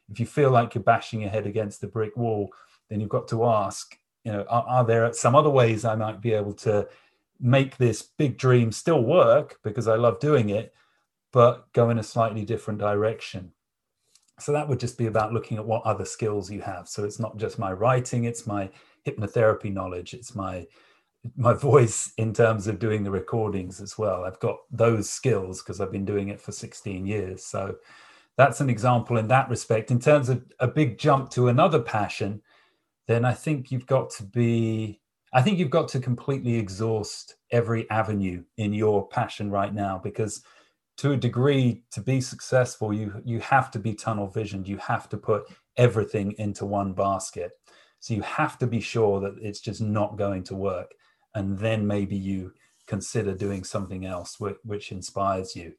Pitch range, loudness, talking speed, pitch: 100-120 Hz, -25 LUFS, 195 wpm, 110 Hz